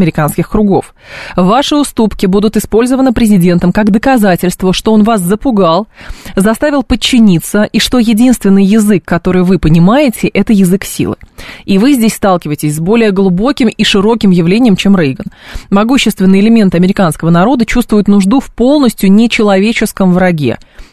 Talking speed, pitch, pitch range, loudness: 135 wpm, 205 Hz, 185-230 Hz, -9 LUFS